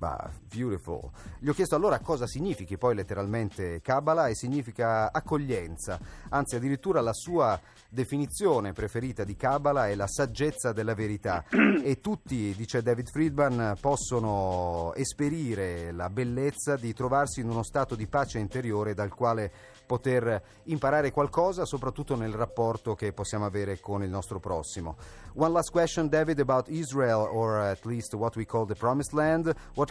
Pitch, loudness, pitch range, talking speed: 120 Hz, -29 LUFS, 105-140 Hz, 150 wpm